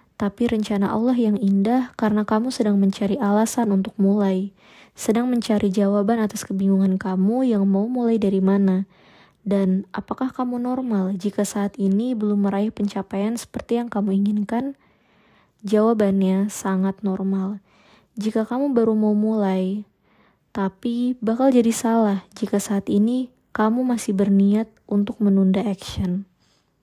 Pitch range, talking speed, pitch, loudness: 195-230 Hz, 130 wpm, 205 Hz, -21 LUFS